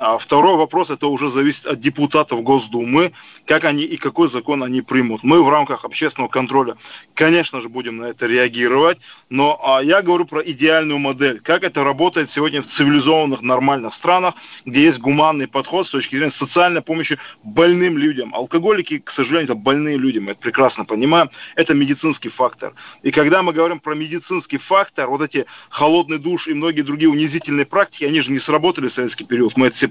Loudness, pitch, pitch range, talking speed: -16 LUFS, 150 Hz, 135-165 Hz, 185 wpm